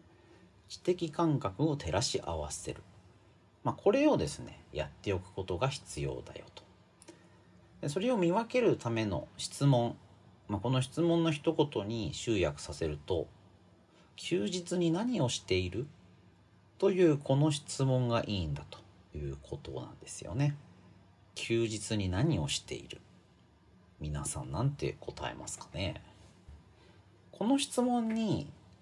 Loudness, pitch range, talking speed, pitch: -33 LUFS, 95-155 Hz, 250 characters per minute, 110 Hz